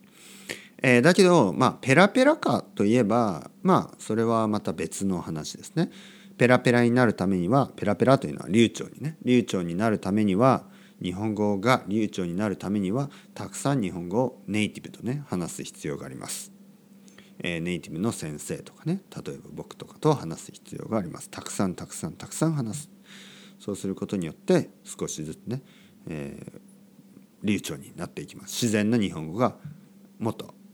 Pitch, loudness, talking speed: 125 Hz, -26 LUFS, 350 characters per minute